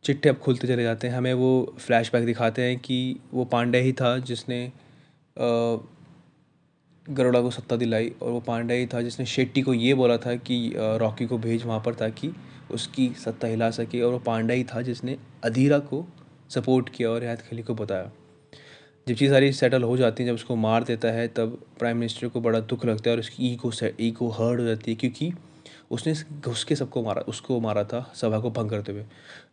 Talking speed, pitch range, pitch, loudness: 205 wpm, 115-130 Hz, 120 Hz, -26 LUFS